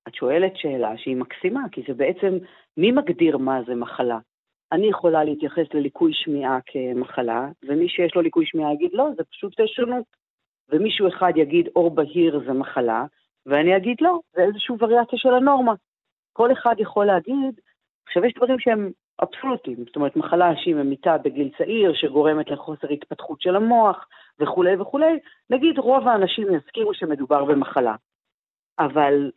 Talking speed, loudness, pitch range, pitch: 150 wpm, -21 LUFS, 145-240 Hz, 175 Hz